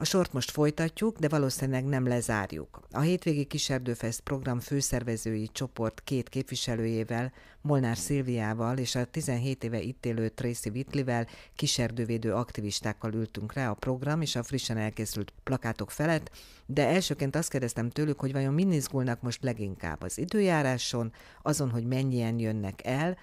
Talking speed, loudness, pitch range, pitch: 140 wpm, -31 LUFS, 115-140 Hz, 125 Hz